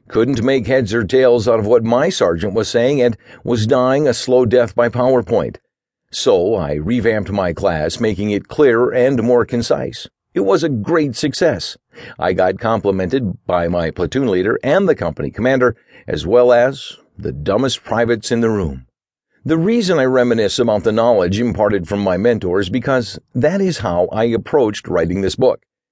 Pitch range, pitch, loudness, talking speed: 100-130 Hz, 120 Hz, -16 LUFS, 175 wpm